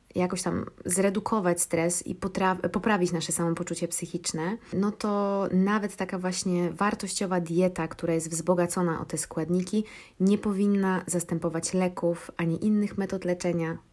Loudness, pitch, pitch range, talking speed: -28 LUFS, 180 Hz, 170-200 Hz, 135 wpm